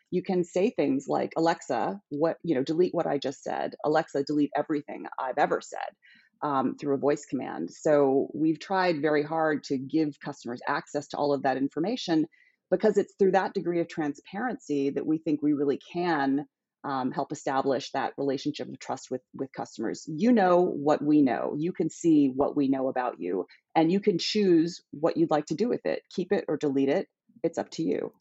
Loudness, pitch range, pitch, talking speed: -28 LUFS, 140-180 Hz, 155 Hz, 200 wpm